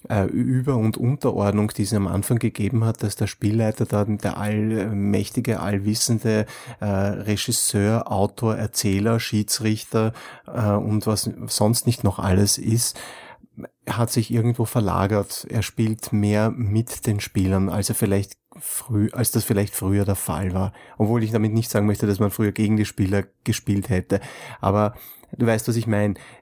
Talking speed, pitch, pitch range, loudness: 155 wpm, 105 Hz, 100-115 Hz, -22 LUFS